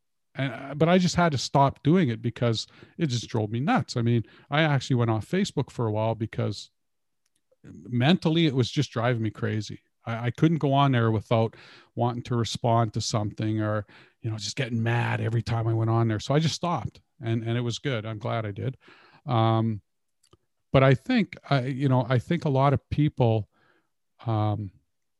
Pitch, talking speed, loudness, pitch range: 120 Hz, 200 wpm, -26 LUFS, 115-140 Hz